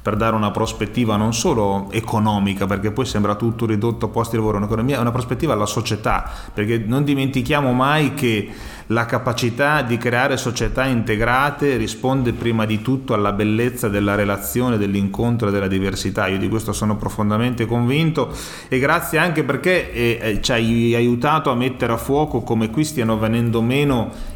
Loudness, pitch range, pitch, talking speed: -19 LUFS, 110-130 Hz, 115 Hz, 170 wpm